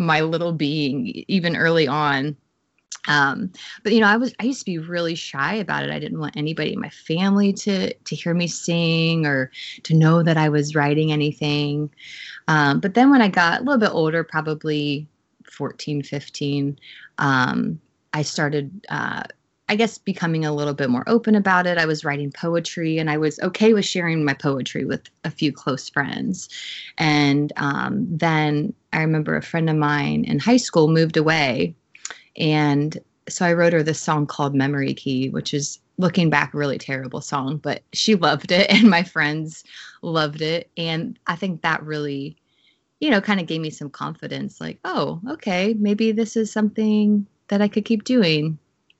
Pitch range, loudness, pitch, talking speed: 145-190 Hz, -21 LUFS, 160 Hz, 185 wpm